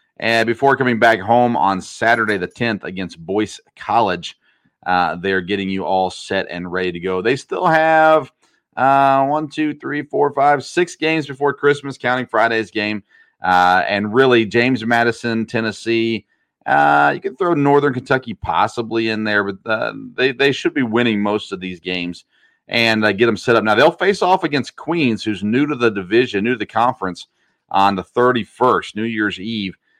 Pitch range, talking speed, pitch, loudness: 100-135 Hz, 180 wpm, 115 Hz, -17 LUFS